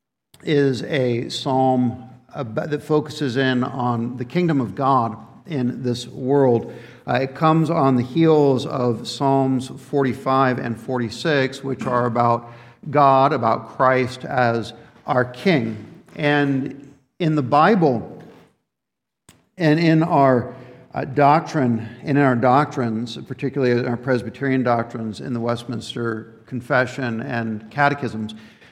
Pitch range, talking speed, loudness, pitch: 120-140 Hz, 125 wpm, -20 LUFS, 130 Hz